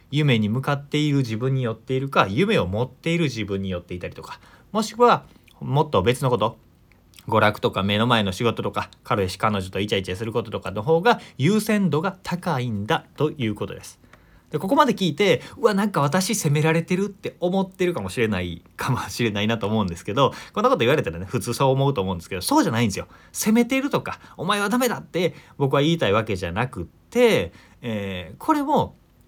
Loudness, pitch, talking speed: -22 LUFS, 130 Hz, 440 characters per minute